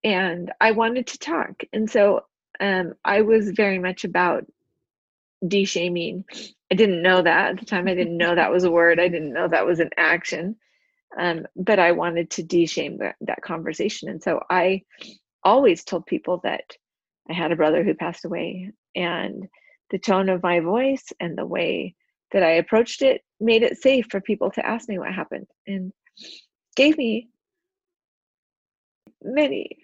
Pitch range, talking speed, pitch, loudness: 175-225 Hz, 175 wpm, 190 Hz, -22 LUFS